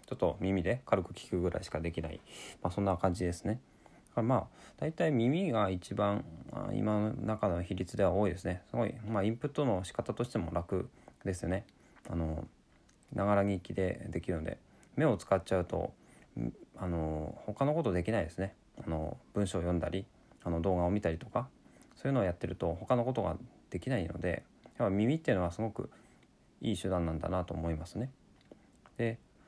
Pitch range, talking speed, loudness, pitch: 85-110 Hz, 345 characters per minute, -35 LUFS, 95 Hz